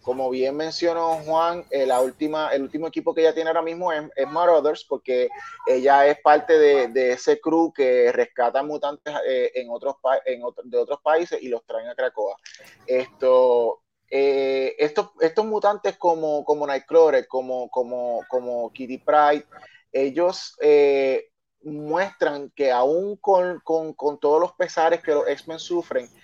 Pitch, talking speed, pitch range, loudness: 160 Hz, 160 wpm, 140-210 Hz, -22 LUFS